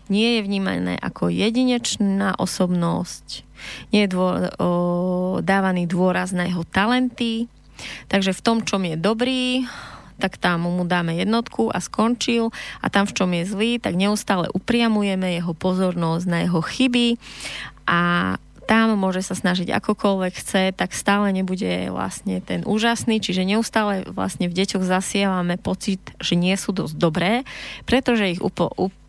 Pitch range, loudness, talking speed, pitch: 175-220 Hz, -21 LUFS, 145 wpm, 190 Hz